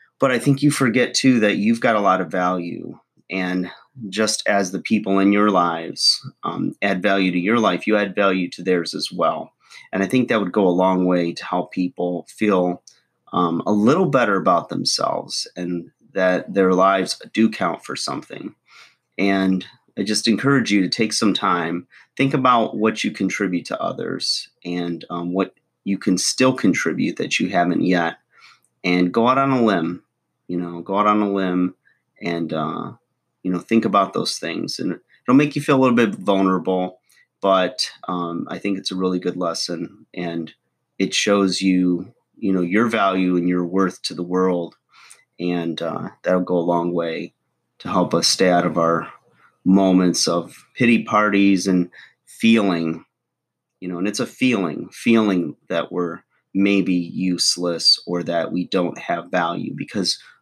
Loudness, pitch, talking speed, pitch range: -20 LUFS, 95 Hz, 180 wpm, 90-105 Hz